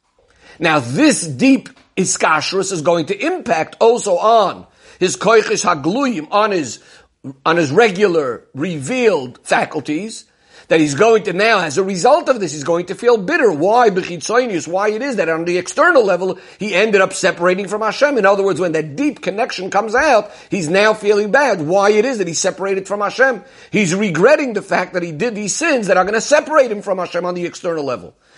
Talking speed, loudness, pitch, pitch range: 195 wpm, -15 LUFS, 200 Hz, 180-235 Hz